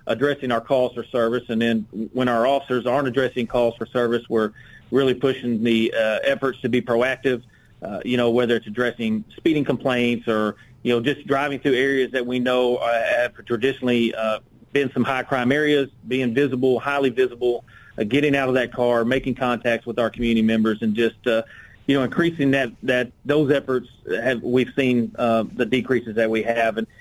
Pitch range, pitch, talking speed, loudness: 115-130 Hz, 125 Hz, 190 wpm, -22 LUFS